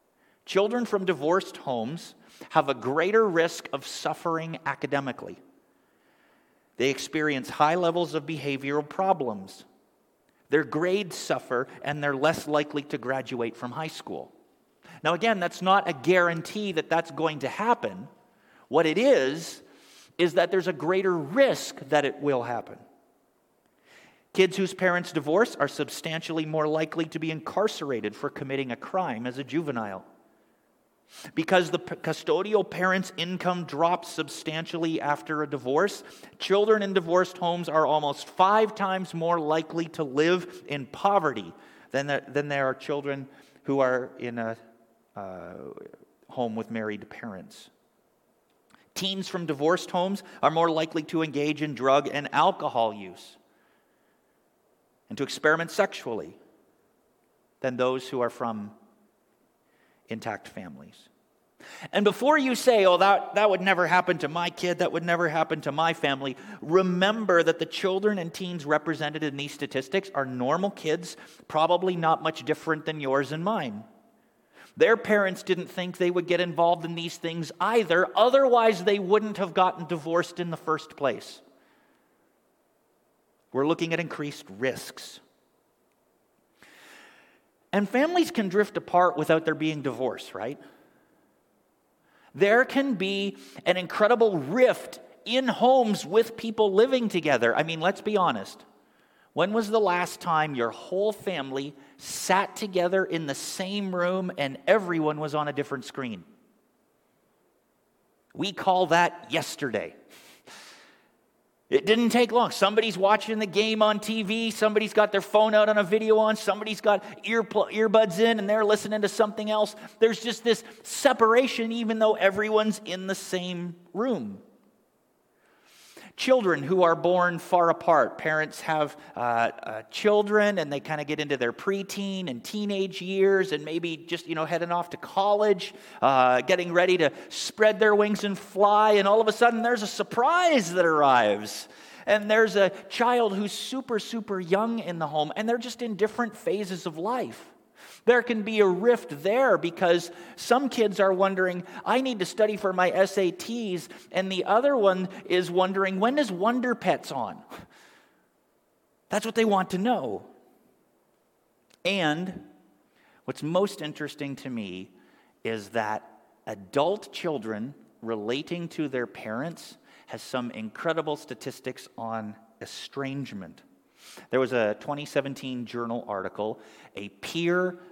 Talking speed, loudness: 145 wpm, -26 LUFS